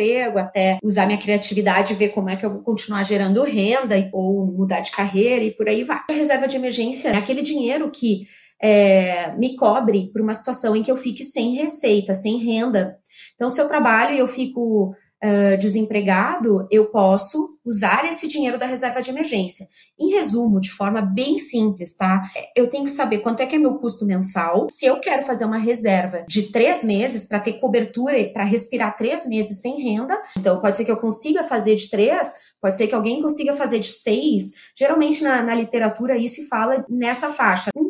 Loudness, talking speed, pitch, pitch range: -19 LUFS, 200 wpm, 225 Hz, 205-255 Hz